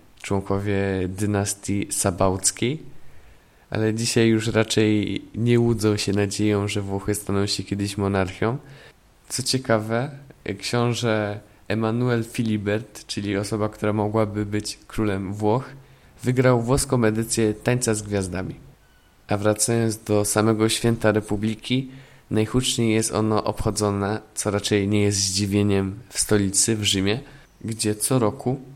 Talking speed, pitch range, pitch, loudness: 120 wpm, 100-115 Hz, 105 Hz, -23 LUFS